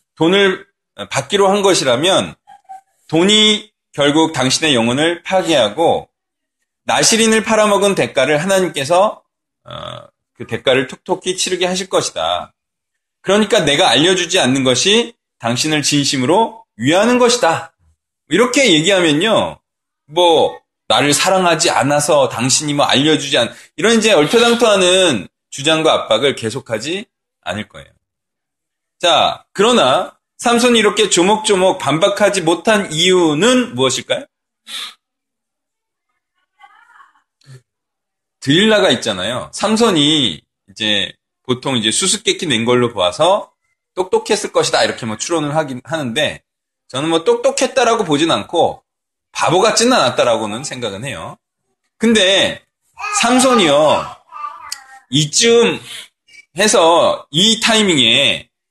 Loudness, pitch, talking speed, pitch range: -13 LUFS, 185 Hz, 255 characters per minute, 145-225 Hz